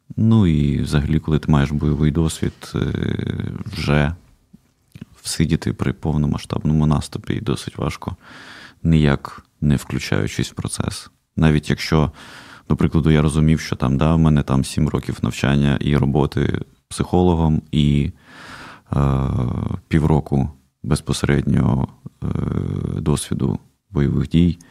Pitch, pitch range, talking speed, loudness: 75 Hz, 70-80 Hz, 115 wpm, -20 LUFS